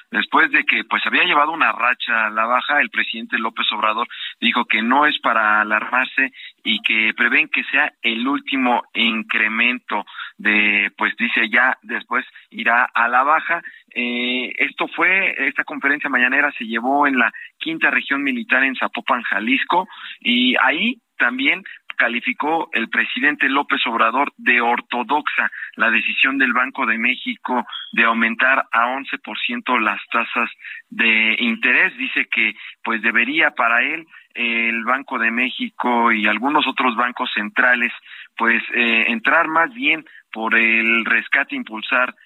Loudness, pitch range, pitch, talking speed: -17 LUFS, 115-150 Hz, 125 Hz, 145 wpm